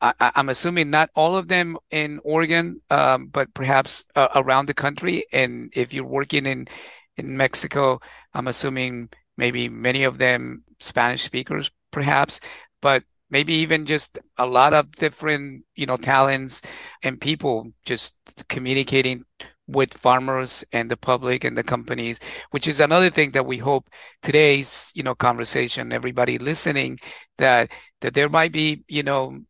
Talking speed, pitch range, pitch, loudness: 155 wpm, 125-150 Hz, 135 Hz, -21 LUFS